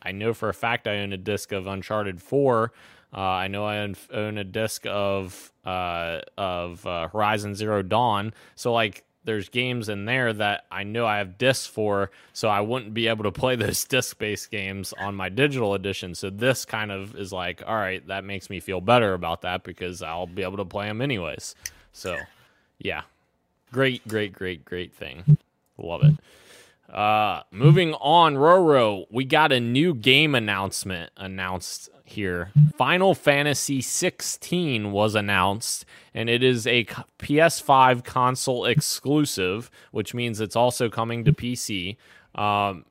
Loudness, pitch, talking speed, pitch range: -24 LUFS, 105 Hz, 165 wpm, 95-125 Hz